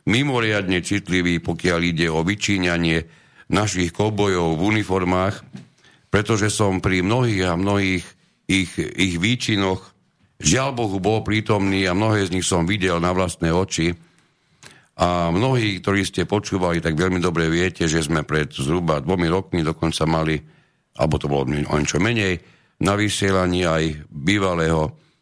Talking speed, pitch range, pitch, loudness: 140 wpm, 85-100 Hz, 95 Hz, -20 LUFS